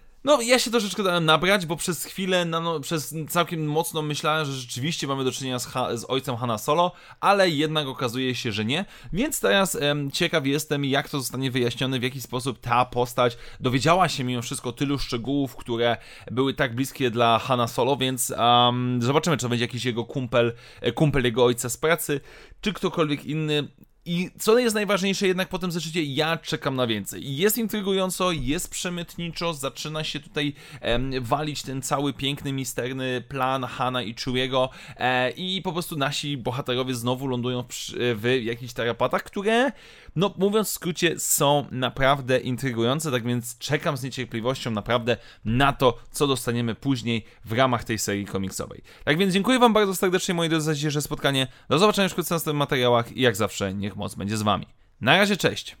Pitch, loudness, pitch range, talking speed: 135 Hz, -24 LUFS, 125-165 Hz, 185 wpm